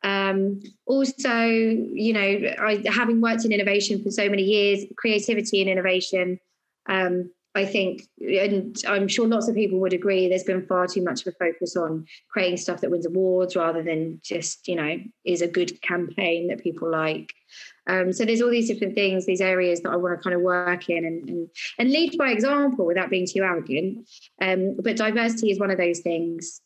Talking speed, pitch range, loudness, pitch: 200 wpm, 180-210 Hz, -23 LUFS, 190 Hz